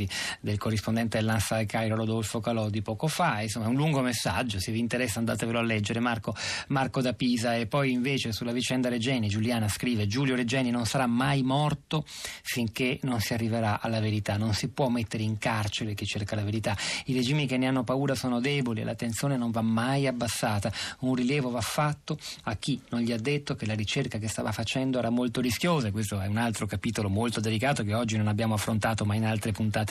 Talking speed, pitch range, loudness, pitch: 210 wpm, 110-130 Hz, -28 LUFS, 120 Hz